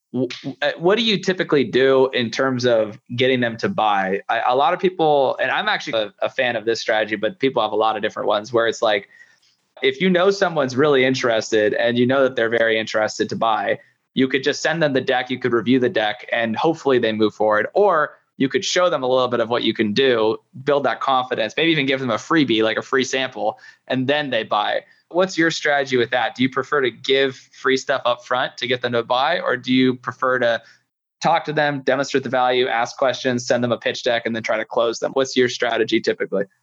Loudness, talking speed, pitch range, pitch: -19 LUFS, 240 wpm, 115-140 Hz, 130 Hz